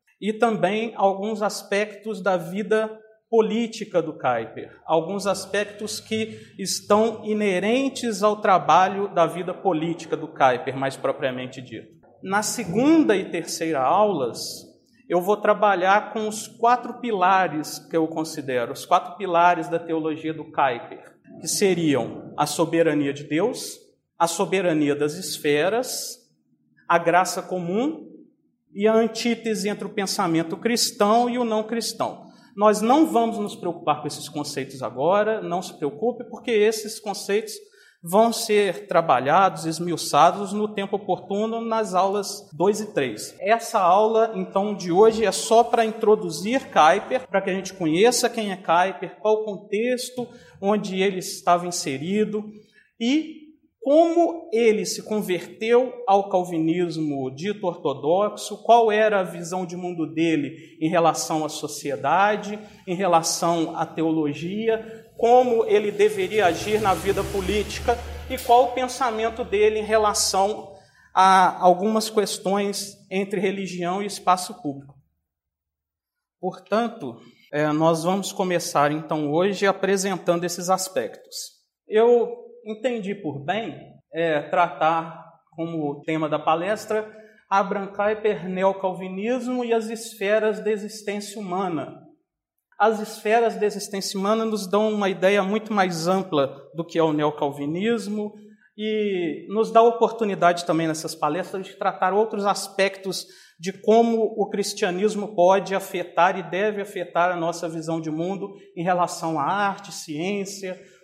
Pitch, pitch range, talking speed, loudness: 195 Hz, 170-220 Hz, 130 wpm, -23 LUFS